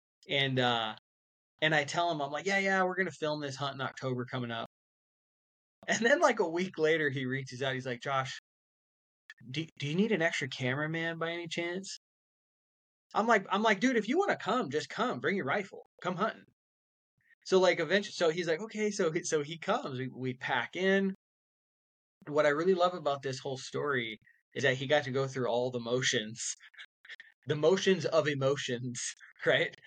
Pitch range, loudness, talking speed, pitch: 130-175 Hz, -31 LUFS, 195 wpm, 150 Hz